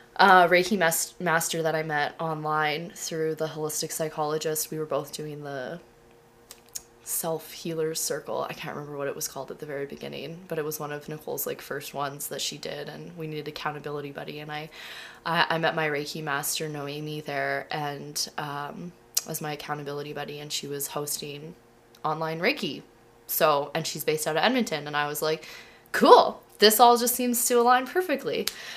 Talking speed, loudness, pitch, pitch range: 190 wpm, -26 LUFS, 155 Hz, 145-165 Hz